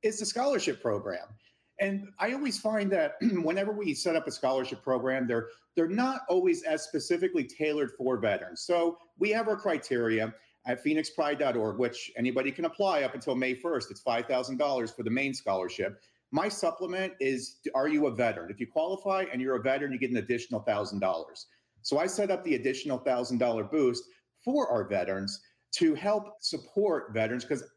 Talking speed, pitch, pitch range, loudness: 175 wpm, 155 Hz, 125-210 Hz, -30 LUFS